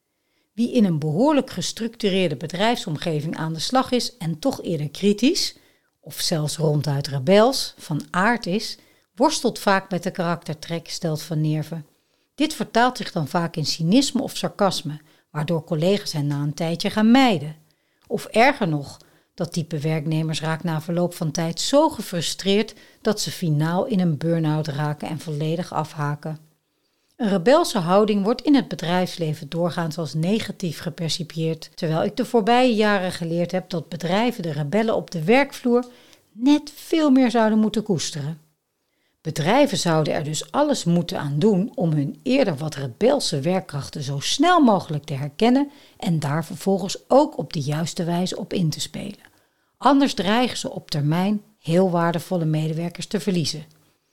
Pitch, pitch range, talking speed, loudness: 175 Hz, 155-220 Hz, 155 wpm, -22 LUFS